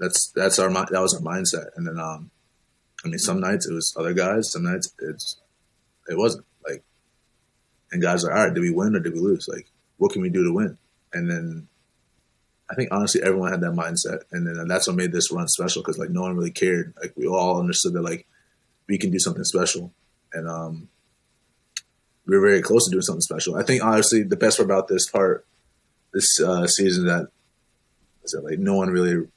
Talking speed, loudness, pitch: 220 wpm, -22 LUFS, 95 Hz